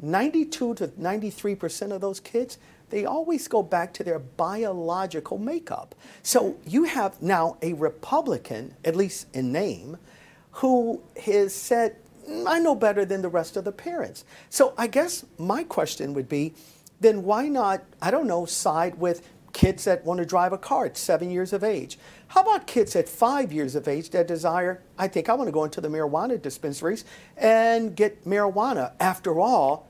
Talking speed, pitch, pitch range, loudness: 180 wpm, 195 Hz, 170-235 Hz, -25 LUFS